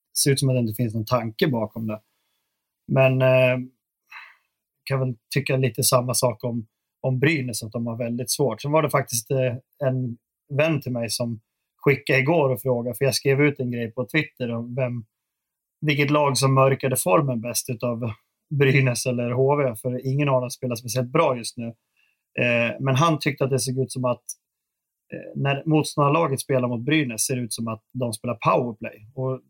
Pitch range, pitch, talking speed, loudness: 120-135 Hz, 130 Hz, 195 wpm, -23 LUFS